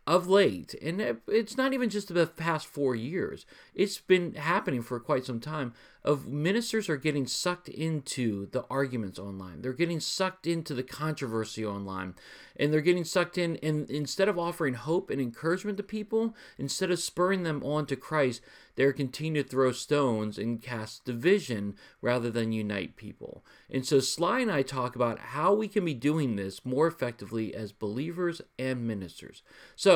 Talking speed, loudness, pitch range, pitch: 175 wpm, -30 LUFS, 120-175 Hz, 145 Hz